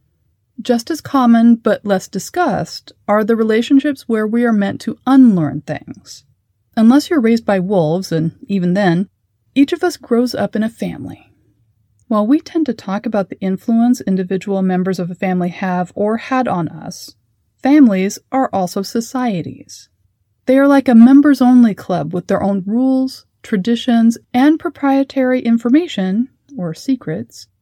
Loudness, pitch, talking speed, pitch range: -15 LUFS, 220 Hz, 155 wpm, 180-255 Hz